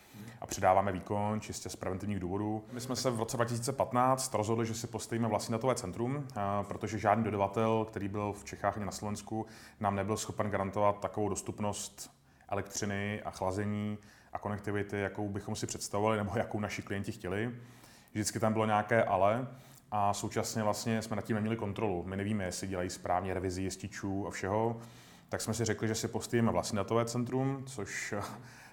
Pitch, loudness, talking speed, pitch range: 105 Hz, -34 LUFS, 175 wpm, 100-115 Hz